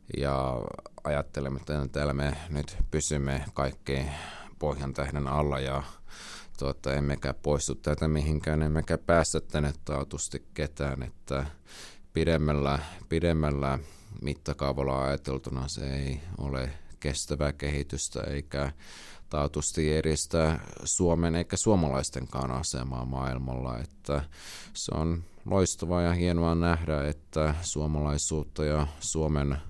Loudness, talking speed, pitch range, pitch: -30 LUFS, 105 wpm, 70-80 Hz, 75 Hz